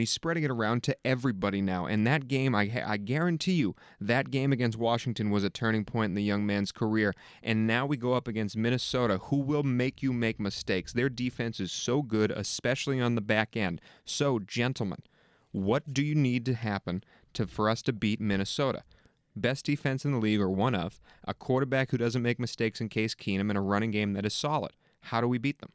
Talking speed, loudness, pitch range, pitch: 215 wpm, -30 LUFS, 105-130 Hz, 120 Hz